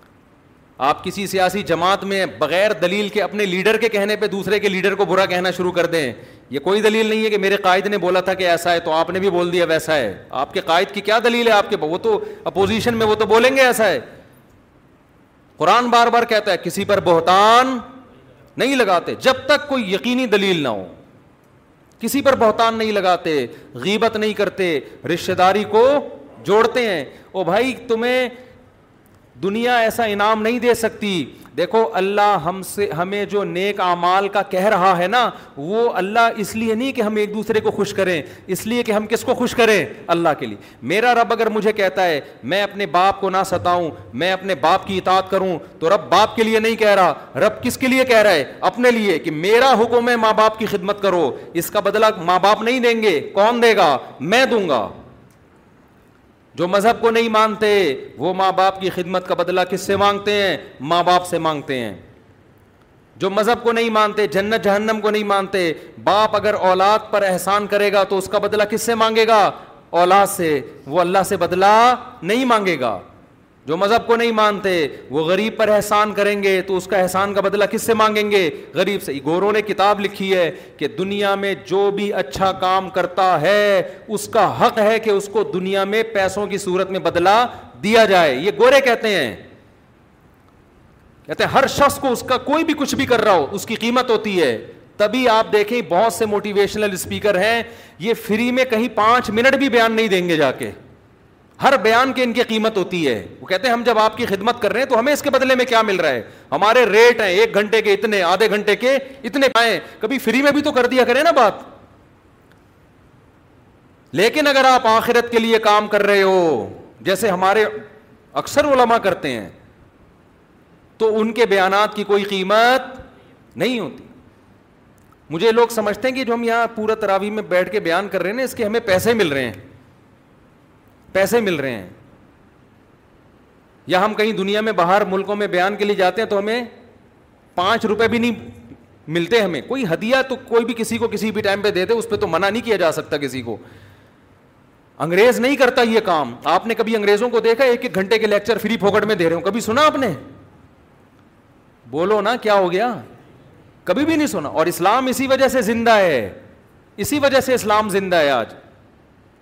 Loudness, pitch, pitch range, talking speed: -17 LUFS, 210 Hz, 185-230 Hz, 205 wpm